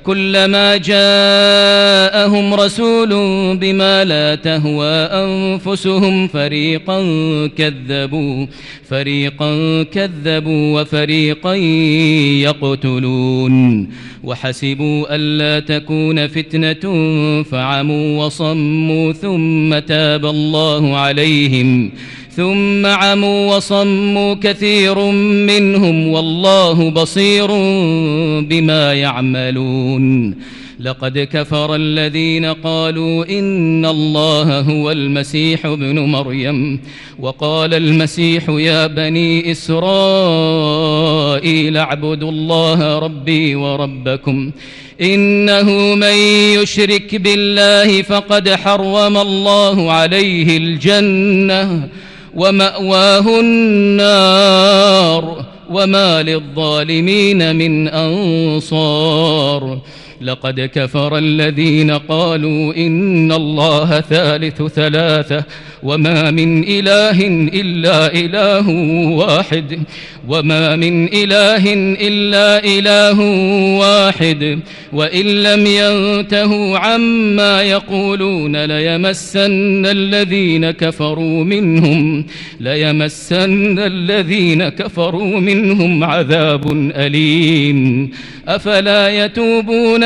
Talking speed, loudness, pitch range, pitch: 70 wpm, -12 LUFS, 150-195 Hz, 160 Hz